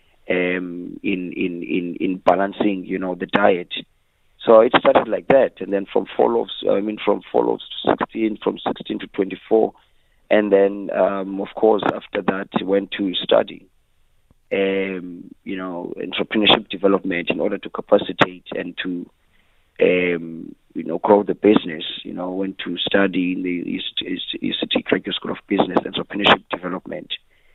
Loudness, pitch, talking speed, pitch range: -20 LUFS, 95 Hz, 160 wpm, 90-100 Hz